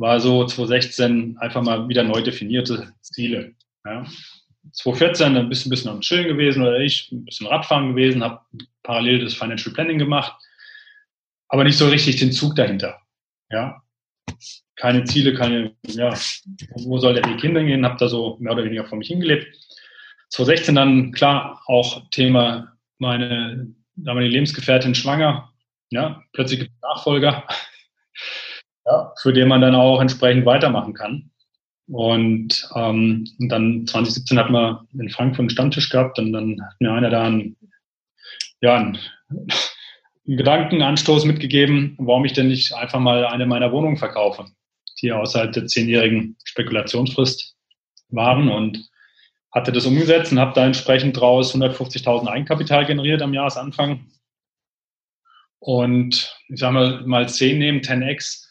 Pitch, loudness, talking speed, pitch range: 125 Hz, -18 LUFS, 145 wpm, 120-140 Hz